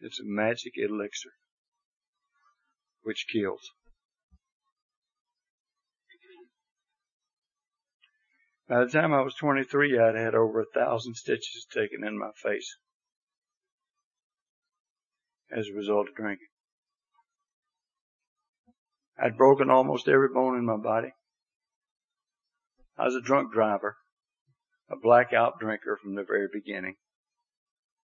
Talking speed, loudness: 100 wpm, -27 LUFS